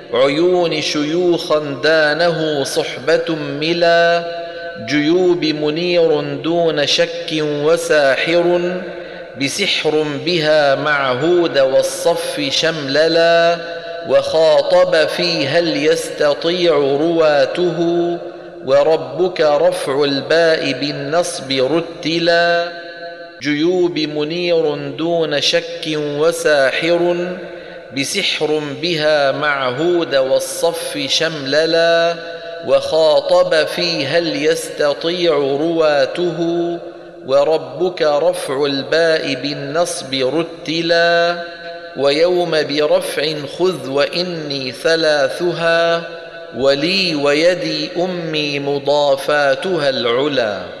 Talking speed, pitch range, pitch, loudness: 65 wpm, 150-170 Hz, 165 Hz, -16 LUFS